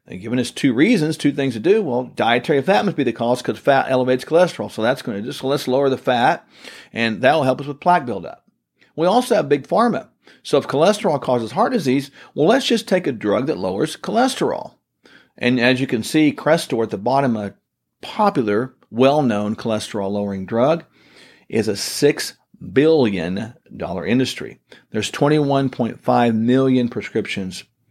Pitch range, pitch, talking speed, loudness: 120-150 Hz, 130 Hz, 175 wpm, -19 LUFS